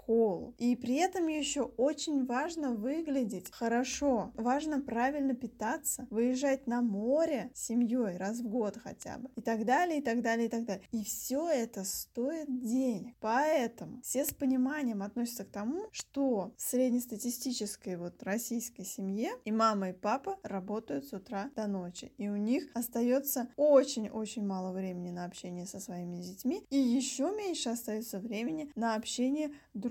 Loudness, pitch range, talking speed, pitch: -34 LUFS, 215-270 Hz, 160 wpm, 240 Hz